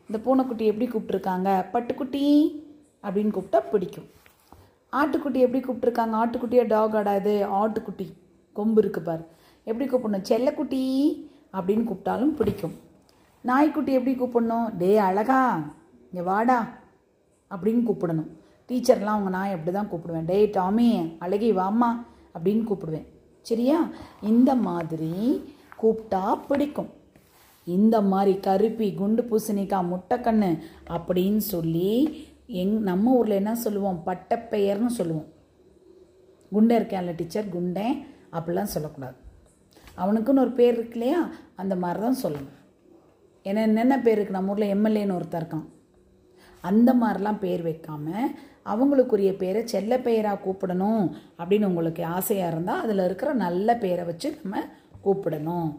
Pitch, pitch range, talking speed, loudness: 210 Hz, 185-245 Hz, 115 wpm, -25 LUFS